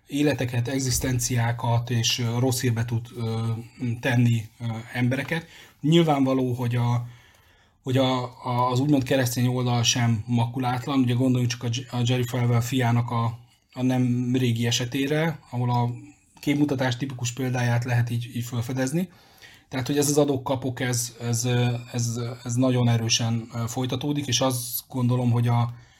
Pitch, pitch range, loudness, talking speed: 125 Hz, 120-130 Hz, -25 LUFS, 135 wpm